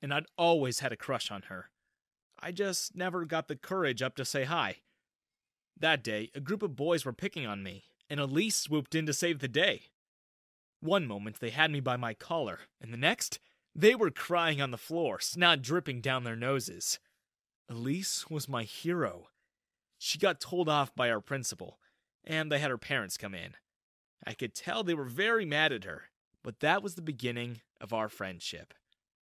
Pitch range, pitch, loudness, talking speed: 120-170 Hz, 145 Hz, -32 LUFS, 190 wpm